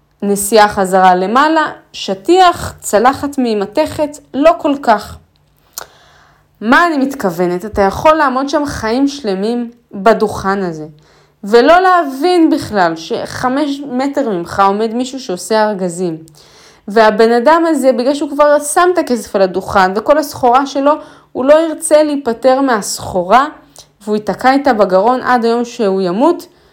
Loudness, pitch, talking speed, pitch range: -12 LUFS, 245 Hz, 130 wpm, 200-295 Hz